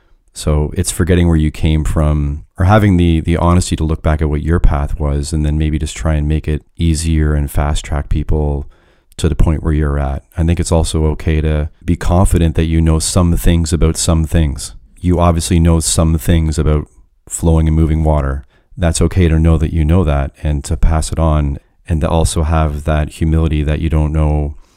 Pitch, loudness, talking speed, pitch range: 80 Hz, -15 LUFS, 215 wpm, 75-85 Hz